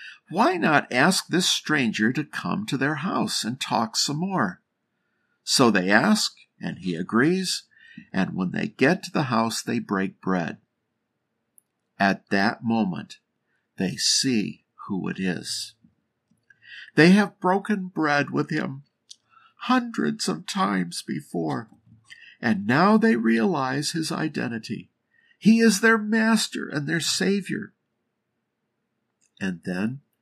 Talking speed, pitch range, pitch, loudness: 125 wpm, 125-210 Hz, 165 Hz, -23 LUFS